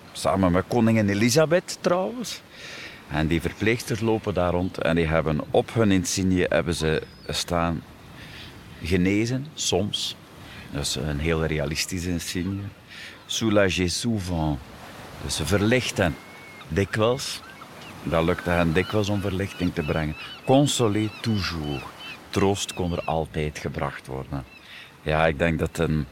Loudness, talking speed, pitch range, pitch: -24 LUFS, 125 wpm, 80-105 Hz, 90 Hz